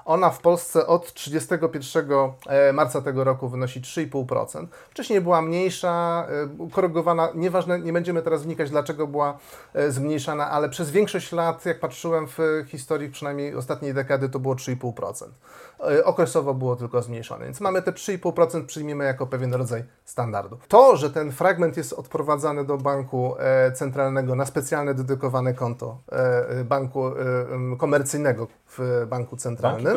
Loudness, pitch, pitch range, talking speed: -24 LUFS, 145 Hz, 130-165 Hz, 135 wpm